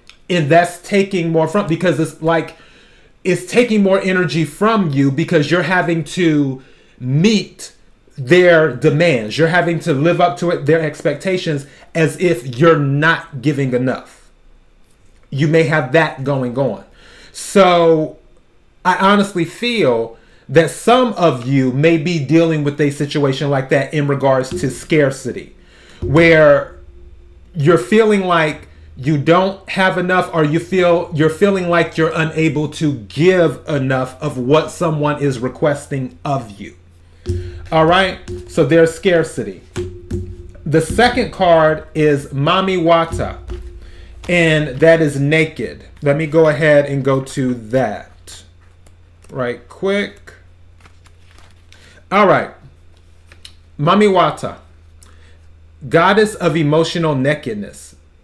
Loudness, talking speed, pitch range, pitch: -15 LUFS, 125 wpm, 120-170 Hz, 155 Hz